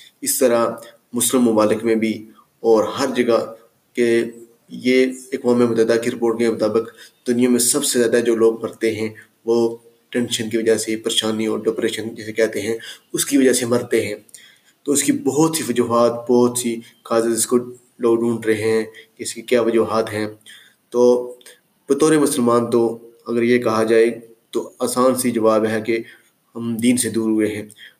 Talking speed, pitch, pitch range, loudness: 180 wpm, 115 Hz, 110-120 Hz, -19 LUFS